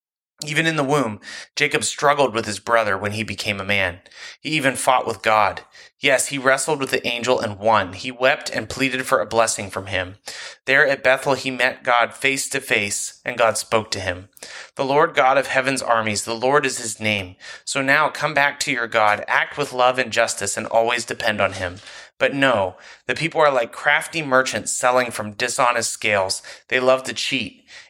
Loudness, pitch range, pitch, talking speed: -20 LUFS, 110-135 Hz, 125 Hz, 200 wpm